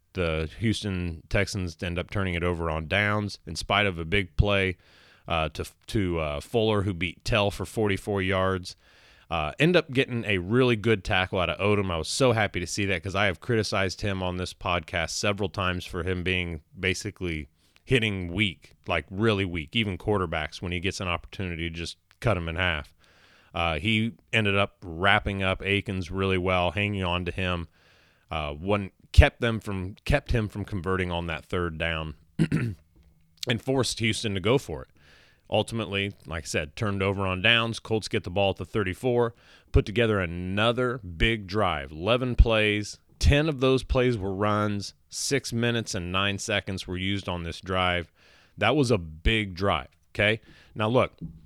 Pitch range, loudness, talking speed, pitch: 85-105 Hz, -27 LUFS, 185 wpm, 95 Hz